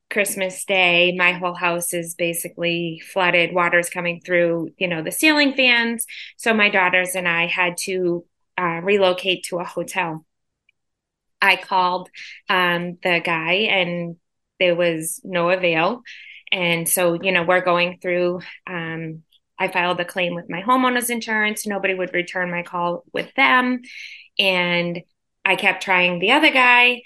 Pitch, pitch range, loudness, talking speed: 180 Hz, 175-190 Hz, -19 LUFS, 150 wpm